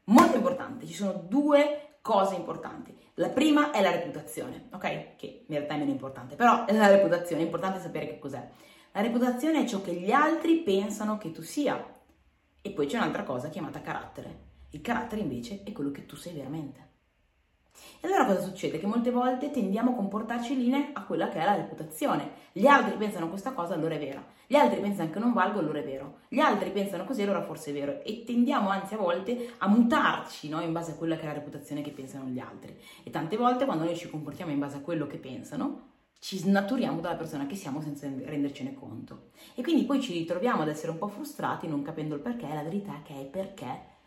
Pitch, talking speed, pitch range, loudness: 195 Hz, 220 wpm, 155-245 Hz, -29 LUFS